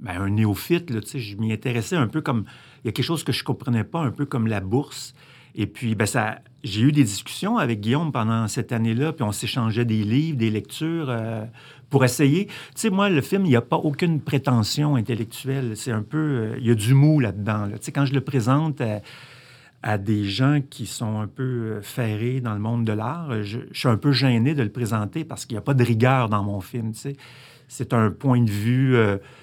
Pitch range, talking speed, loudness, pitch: 110-140 Hz, 245 wpm, -23 LUFS, 125 Hz